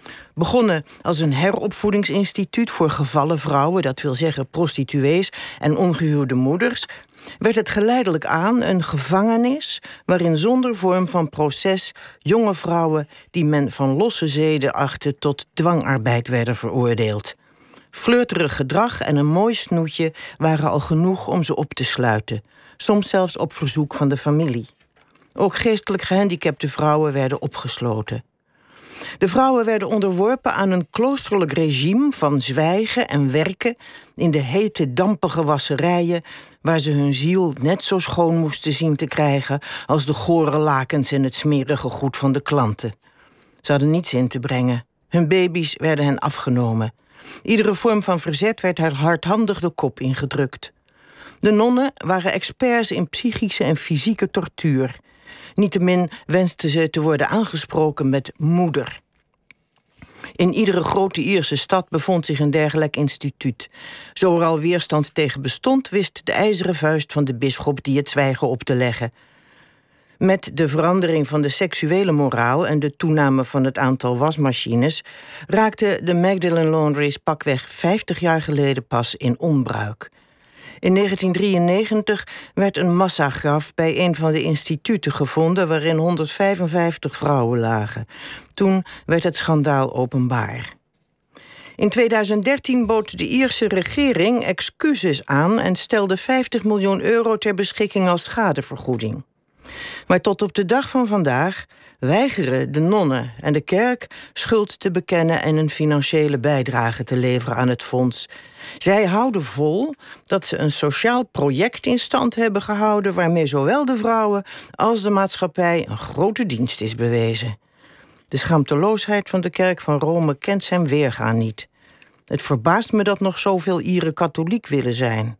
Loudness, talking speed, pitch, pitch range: -19 LUFS, 145 wpm, 160 Hz, 140-195 Hz